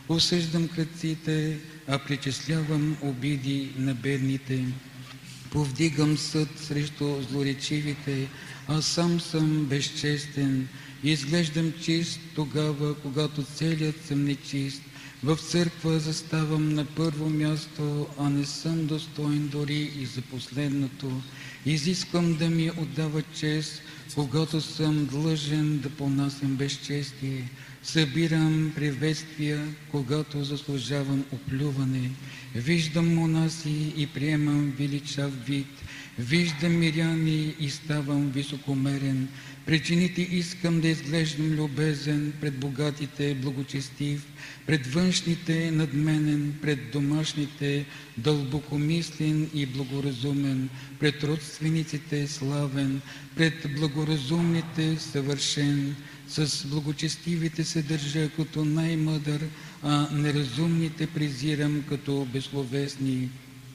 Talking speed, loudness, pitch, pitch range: 90 wpm, -28 LUFS, 150 Hz, 140-155 Hz